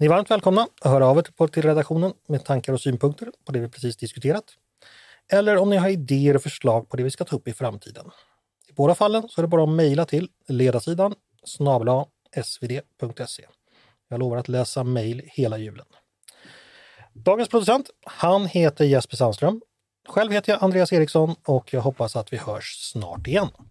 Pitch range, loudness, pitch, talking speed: 125-180 Hz, -22 LUFS, 140 Hz, 180 wpm